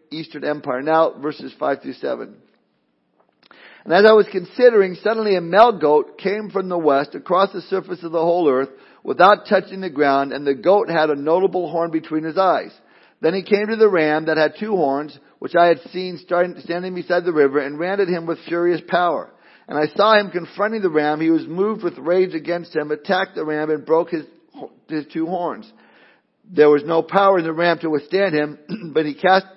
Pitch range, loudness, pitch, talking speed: 155-190 Hz, -19 LUFS, 170 Hz, 205 wpm